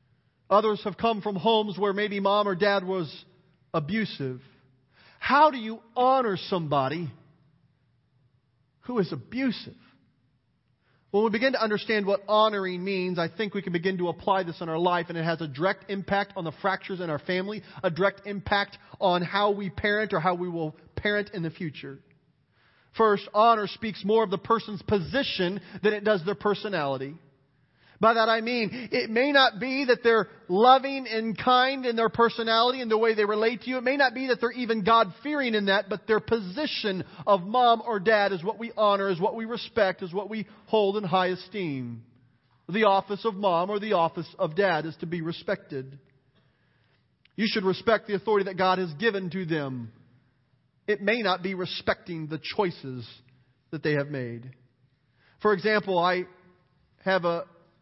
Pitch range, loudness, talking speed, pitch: 160-220 Hz, -26 LUFS, 180 wpm, 195 Hz